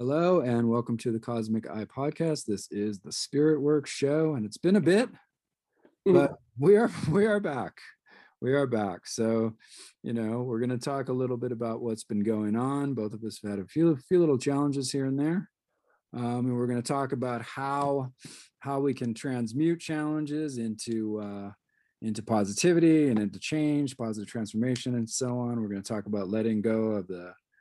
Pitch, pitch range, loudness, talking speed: 125 Hz, 110-145 Hz, -28 LUFS, 200 wpm